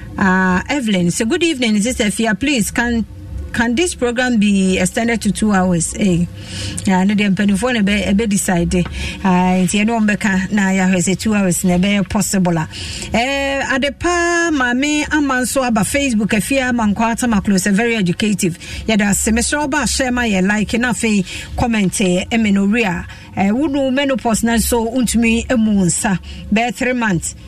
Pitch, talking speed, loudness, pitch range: 215 Hz, 175 wpm, -16 LUFS, 190-245 Hz